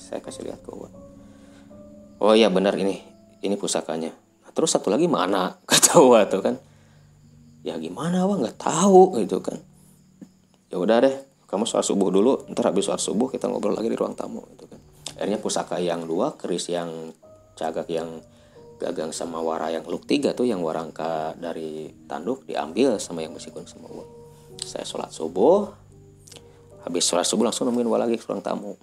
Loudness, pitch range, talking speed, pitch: -23 LUFS, 80-100 Hz, 170 wpm, 85 Hz